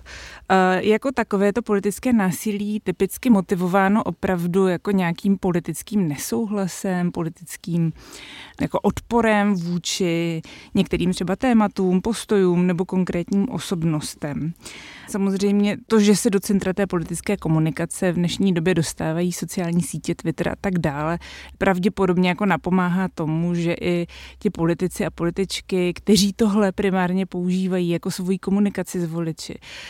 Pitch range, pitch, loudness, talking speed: 175-205 Hz, 185 Hz, -22 LUFS, 125 wpm